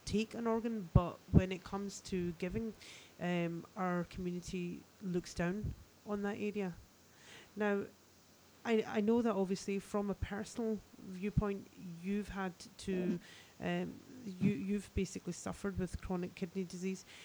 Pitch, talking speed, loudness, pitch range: 195 Hz, 135 wpm, -39 LUFS, 180-210 Hz